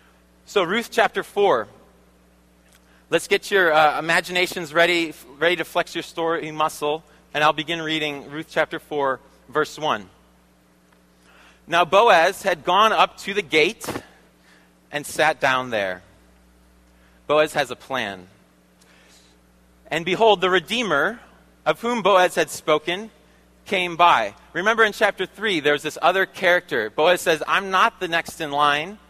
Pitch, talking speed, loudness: 155 Hz, 140 wpm, -20 LUFS